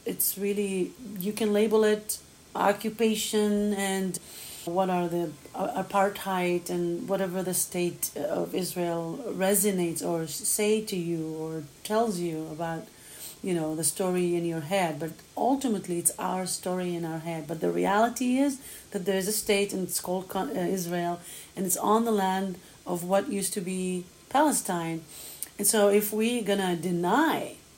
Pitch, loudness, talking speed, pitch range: 185 Hz, -28 LUFS, 160 wpm, 175-205 Hz